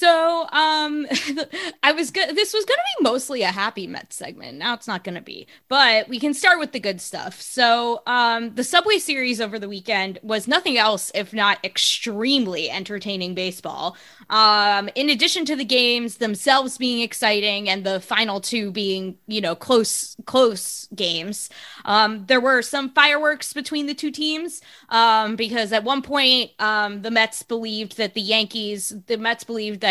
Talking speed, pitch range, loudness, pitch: 180 wpm, 210-290 Hz, -20 LUFS, 230 Hz